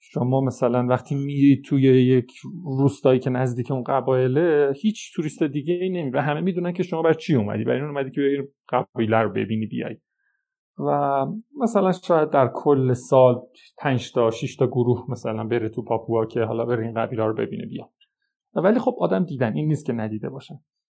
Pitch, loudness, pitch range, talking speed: 135 Hz, -22 LUFS, 125-165 Hz, 185 wpm